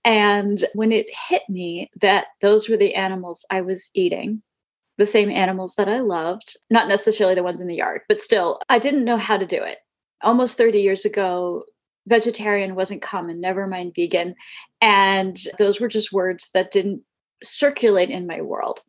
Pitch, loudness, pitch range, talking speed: 205 Hz, -20 LUFS, 185-225 Hz, 180 wpm